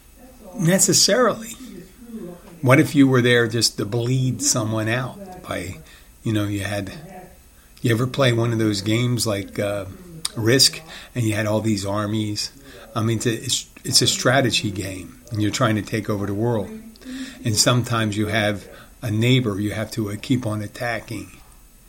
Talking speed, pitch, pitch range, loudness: 165 wpm, 115 Hz, 105-135 Hz, -20 LUFS